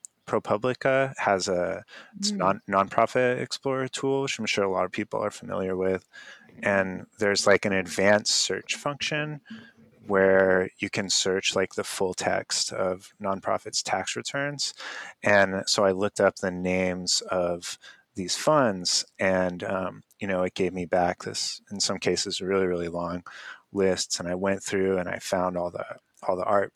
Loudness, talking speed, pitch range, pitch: -26 LUFS, 170 wpm, 95-115 Hz, 95 Hz